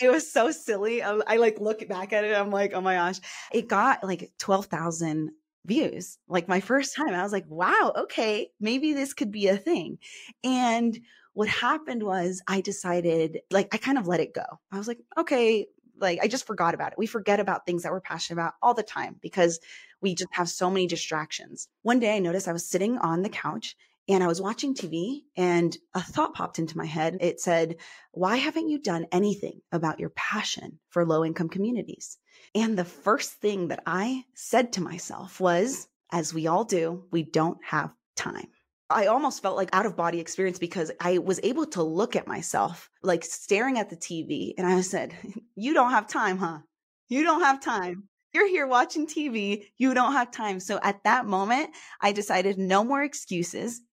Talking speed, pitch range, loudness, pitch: 200 wpm, 175-240 Hz, -27 LUFS, 200 Hz